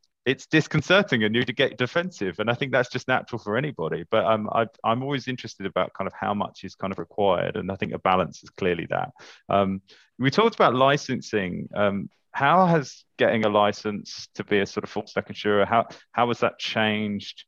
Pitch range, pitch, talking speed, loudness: 105-135 Hz, 115 Hz, 210 wpm, -24 LUFS